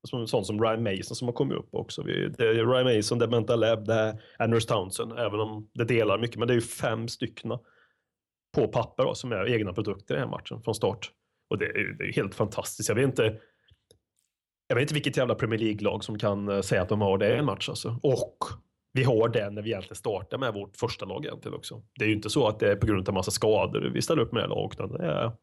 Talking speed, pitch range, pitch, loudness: 255 wpm, 105-120 Hz, 115 Hz, -28 LUFS